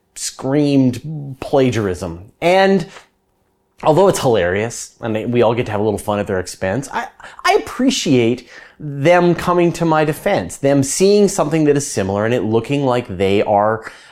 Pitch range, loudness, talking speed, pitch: 110-165 Hz, -16 LUFS, 160 wpm, 135 Hz